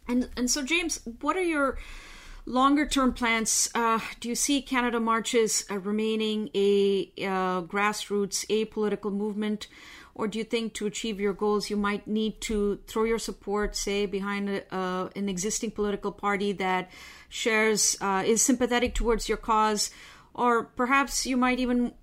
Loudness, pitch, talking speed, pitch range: -27 LUFS, 215 Hz, 165 wpm, 205-240 Hz